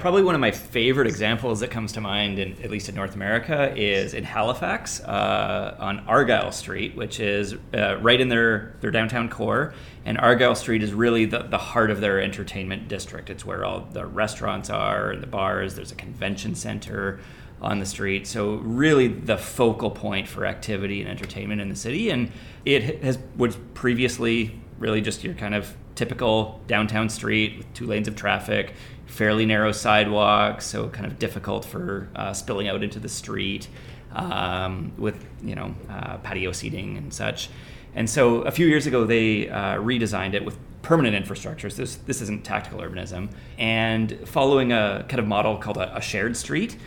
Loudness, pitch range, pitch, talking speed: -24 LUFS, 100-120 Hz, 110 Hz, 185 wpm